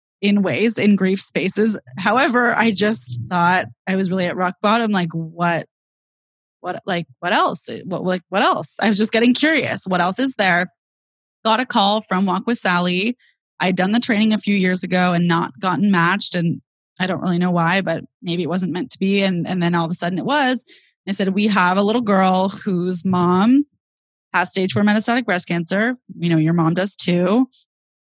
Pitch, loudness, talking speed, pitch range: 190 Hz, -18 LUFS, 205 wpm, 175-210 Hz